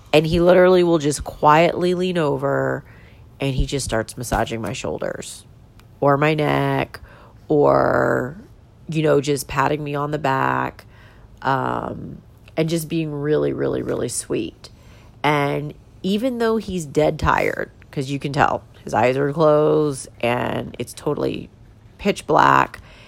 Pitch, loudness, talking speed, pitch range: 140 Hz, -20 LUFS, 140 wpm, 115-155 Hz